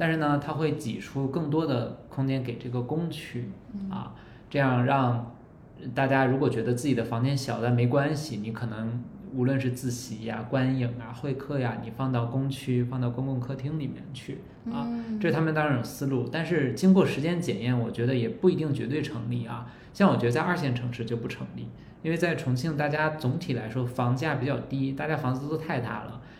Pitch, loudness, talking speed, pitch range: 130 Hz, -28 LUFS, 300 characters per minute, 120-150 Hz